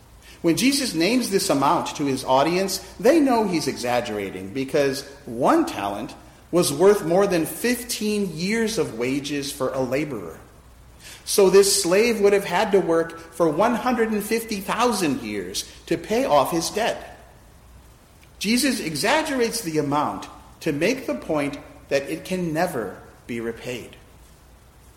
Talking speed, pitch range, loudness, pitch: 135 wpm, 140-215 Hz, -22 LUFS, 175 Hz